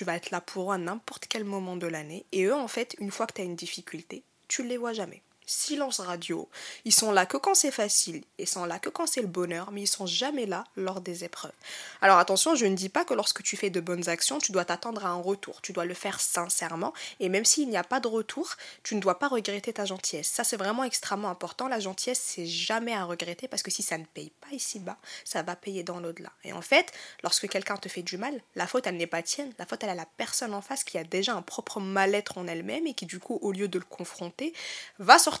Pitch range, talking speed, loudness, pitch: 180-235 Hz, 270 wpm, -28 LUFS, 200 Hz